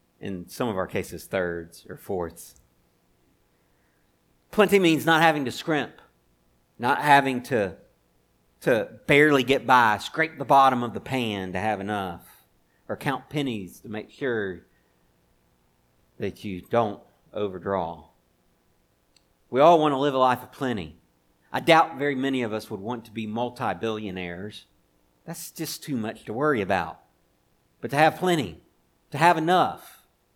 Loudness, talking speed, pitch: -24 LUFS, 150 wpm, 100 Hz